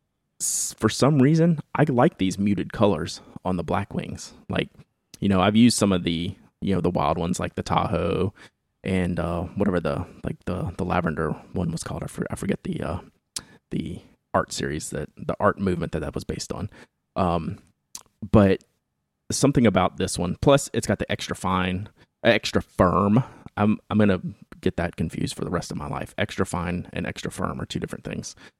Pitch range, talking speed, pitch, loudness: 90-110 Hz, 195 wpm, 100 Hz, -24 LUFS